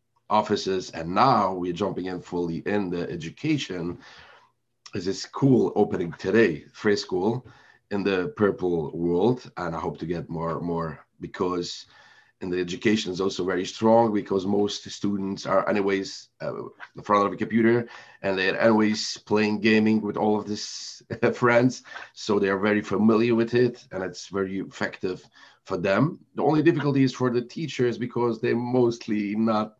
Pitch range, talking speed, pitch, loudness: 95-115 Hz, 165 wpm, 105 Hz, -25 LUFS